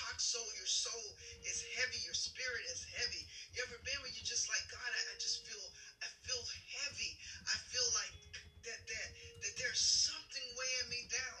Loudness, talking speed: -39 LUFS, 185 wpm